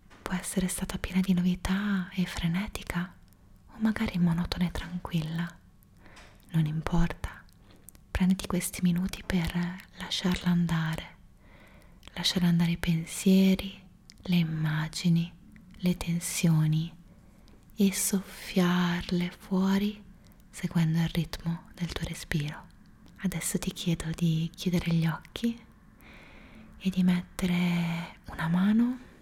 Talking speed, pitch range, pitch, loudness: 105 wpm, 165-190 Hz, 175 Hz, -29 LUFS